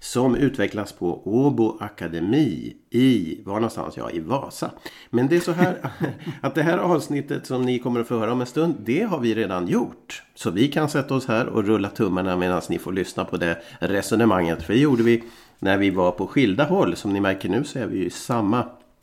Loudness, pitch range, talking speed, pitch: -23 LUFS, 95-135 Hz, 215 wpm, 115 Hz